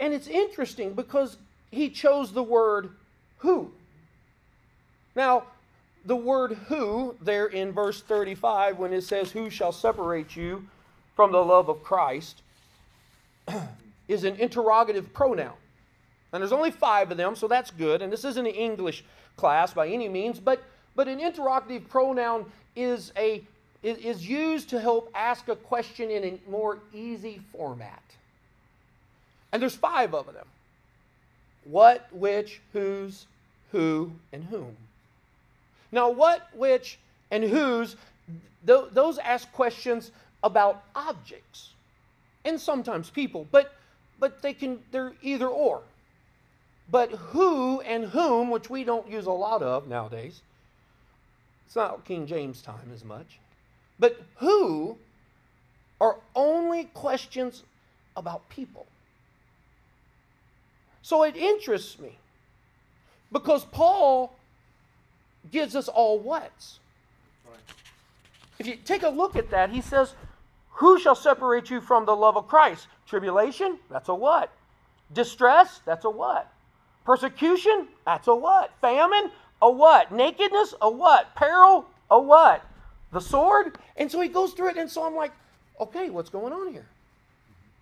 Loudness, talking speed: -24 LUFS, 135 wpm